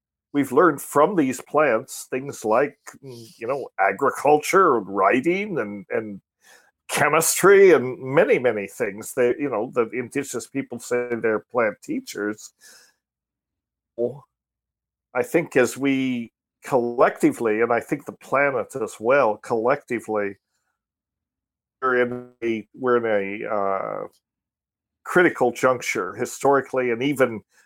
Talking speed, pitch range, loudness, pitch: 115 wpm, 110-140 Hz, -22 LUFS, 125 Hz